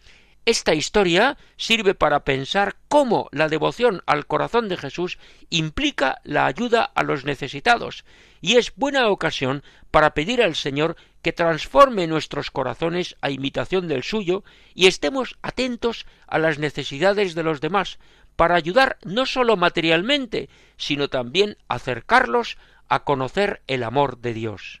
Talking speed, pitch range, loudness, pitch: 140 wpm, 150-230 Hz, -21 LUFS, 175 Hz